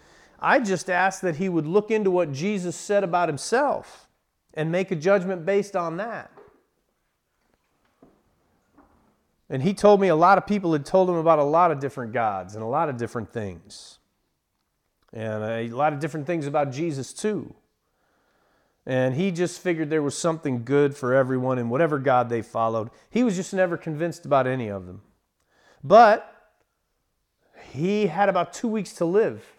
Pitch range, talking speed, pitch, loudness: 130-190 Hz, 170 wpm, 165 Hz, -23 LUFS